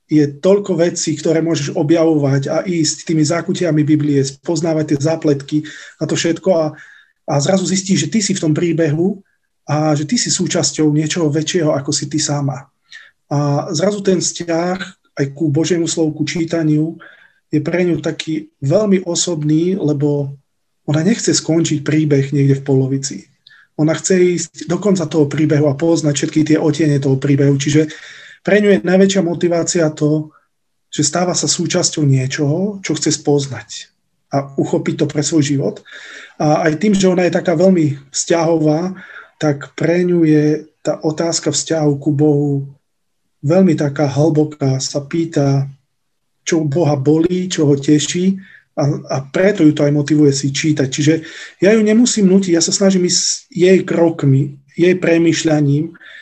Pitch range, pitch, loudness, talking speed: 150-175 Hz, 155 Hz, -15 LUFS, 160 wpm